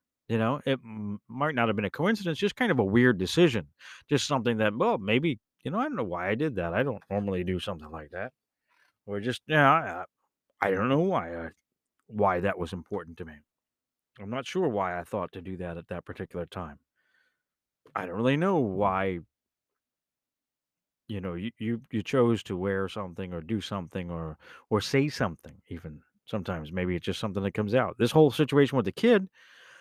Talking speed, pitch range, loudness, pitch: 205 wpm, 90-130 Hz, -28 LUFS, 105 Hz